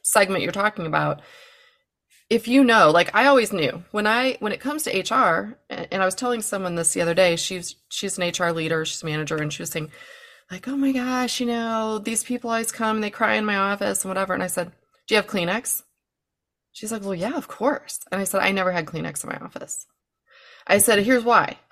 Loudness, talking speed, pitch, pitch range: -22 LUFS, 230 wpm, 215 Hz, 185-245 Hz